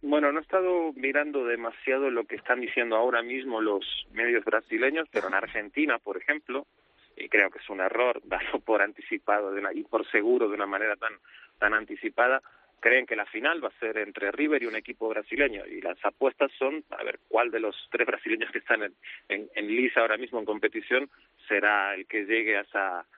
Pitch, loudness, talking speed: 150 Hz, -28 LUFS, 200 wpm